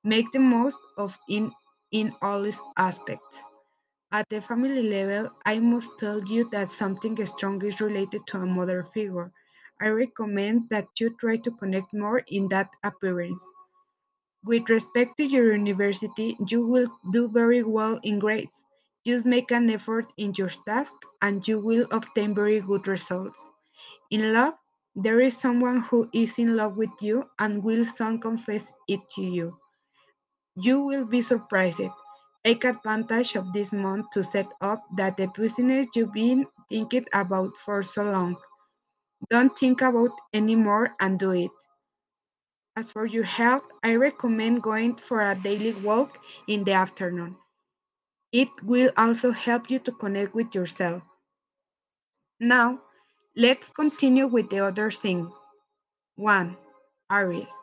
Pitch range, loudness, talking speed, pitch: 200-235 Hz, -25 LUFS, 150 wpm, 215 Hz